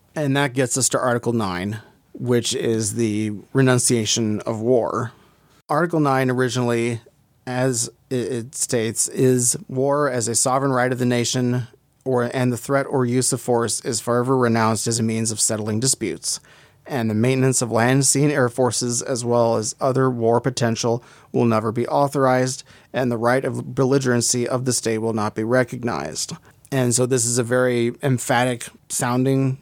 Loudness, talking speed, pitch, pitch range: -20 LUFS, 170 wpm, 125 Hz, 115-130 Hz